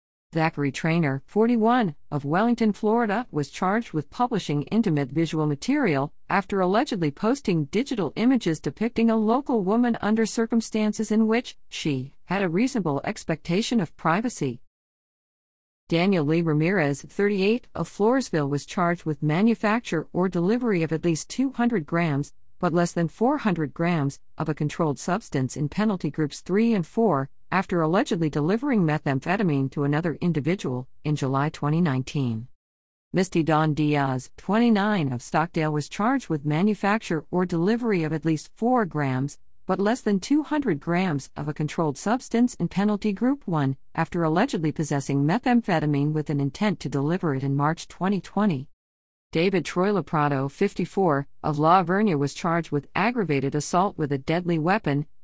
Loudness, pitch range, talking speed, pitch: -24 LUFS, 150-210 Hz, 145 wpm, 170 Hz